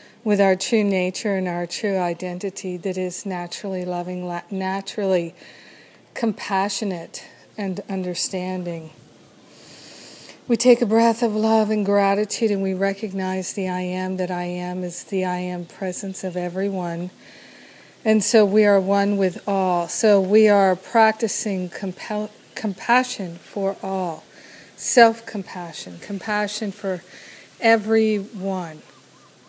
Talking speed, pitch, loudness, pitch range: 120 wpm, 195 Hz, -22 LUFS, 180-210 Hz